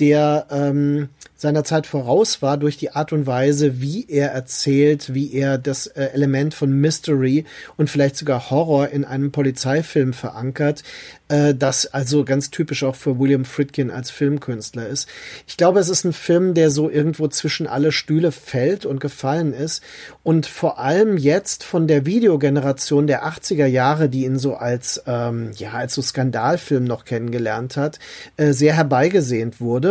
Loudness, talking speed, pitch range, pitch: -19 LUFS, 165 wpm, 135-155 Hz, 145 Hz